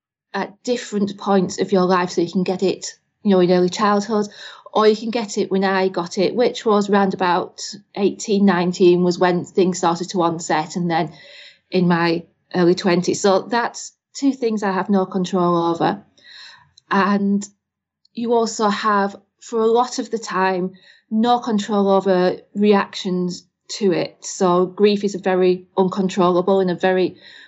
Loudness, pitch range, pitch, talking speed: -19 LUFS, 180-210 Hz, 195 Hz, 170 wpm